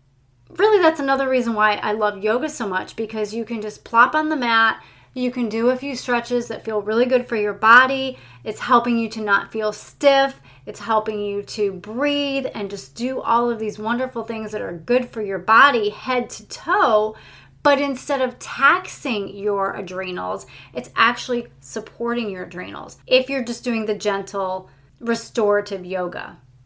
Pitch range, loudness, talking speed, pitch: 205-250 Hz, -20 LUFS, 180 wpm, 225 Hz